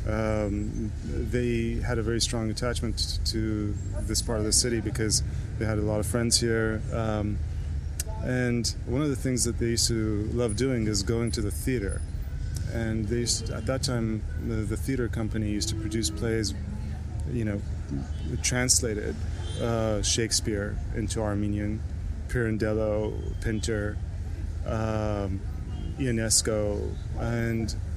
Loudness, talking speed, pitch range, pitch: -28 LUFS, 140 wpm, 95-115 Hz, 105 Hz